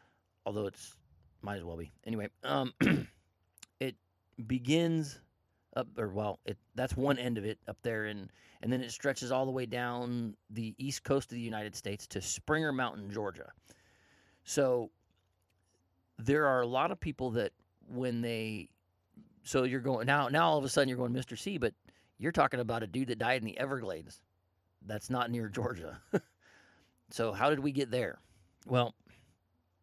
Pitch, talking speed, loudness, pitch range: 115 Hz, 175 wpm, -34 LUFS, 100-130 Hz